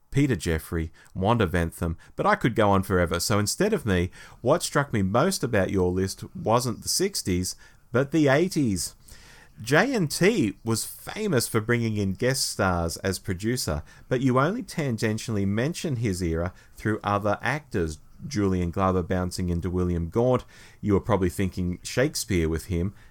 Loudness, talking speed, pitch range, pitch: -25 LUFS, 160 wpm, 90-125 Hz, 105 Hz